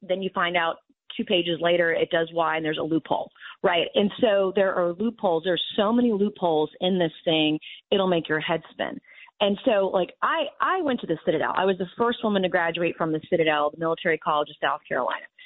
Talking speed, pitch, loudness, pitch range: 220 wpm, 180 Hz, -24 LUFS, 165-200 Hz